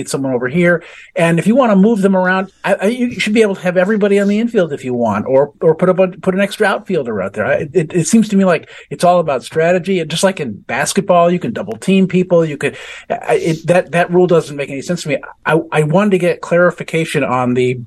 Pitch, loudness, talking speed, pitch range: 180 Hz, -14 LUFS, 260 wpm, 155-195 Hz